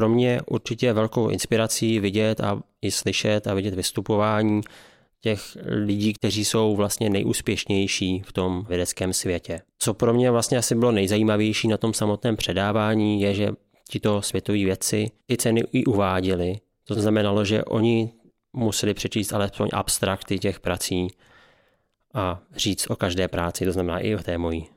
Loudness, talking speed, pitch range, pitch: -23 LUFS, 155 wpm, 95-110 Hz, 105 Hz